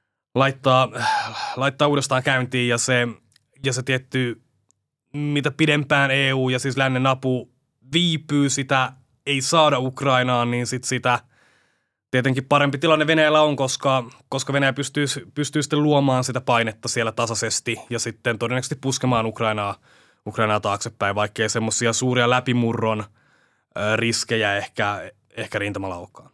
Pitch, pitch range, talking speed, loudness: 130 Hz, 115-140 Hz, 125 wpm, -21 LUFS